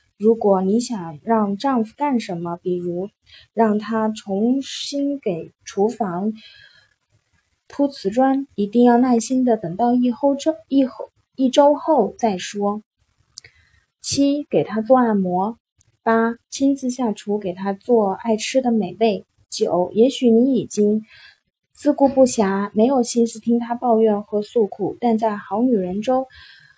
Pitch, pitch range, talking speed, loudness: 230 Hz, 205-255 Hz, 195 characters per minute, -20 LUFS